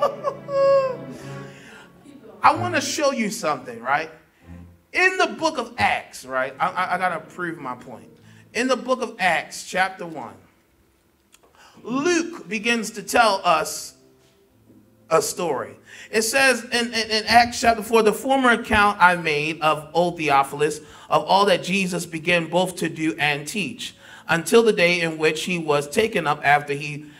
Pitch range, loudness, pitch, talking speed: 150-230 Hz, -21 LUFS, 180 Hz, 160 wpm